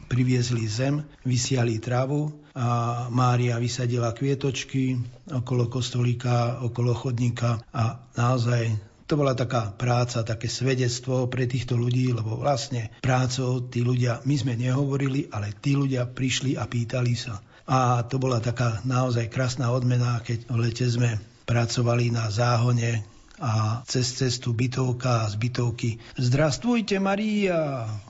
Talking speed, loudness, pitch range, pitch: 130 wpm, -25 LUFS, 120-130 Hz, 125 Hz